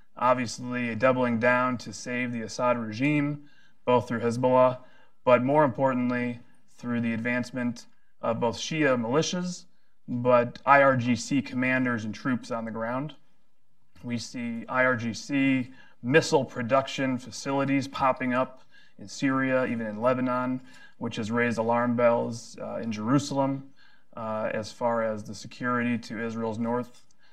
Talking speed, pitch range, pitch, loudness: 130 wpm, 120-135 Hz, 125 Hz, -27 LUFS